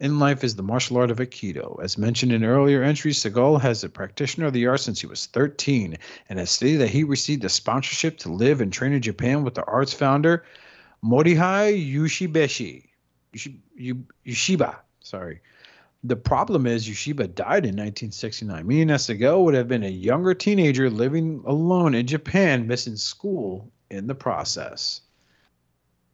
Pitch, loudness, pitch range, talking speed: 130 Hz, -22 LUFS, 115-150 Hz, 165 wpm